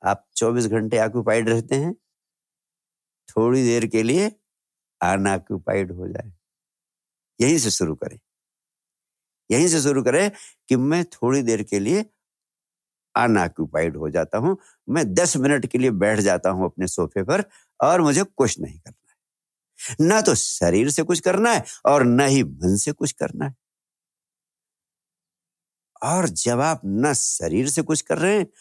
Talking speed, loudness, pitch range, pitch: 155 wpm, -21 LUFS, 110-165 Hz, 130 Hz